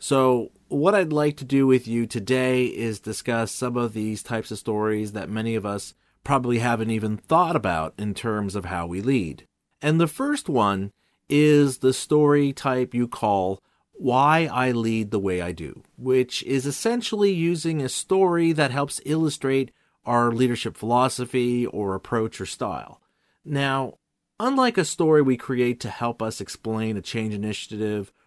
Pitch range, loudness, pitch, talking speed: 110-140 Hz, -23 LUFS, 120 Hz, 165 wpm